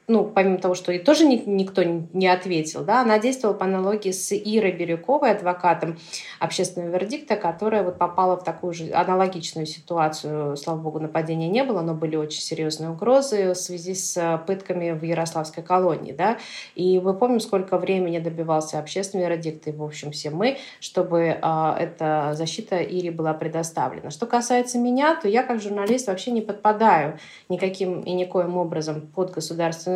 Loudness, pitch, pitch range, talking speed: -23 LUFS, 180 Hz, 165-200 Hz, 165 wpm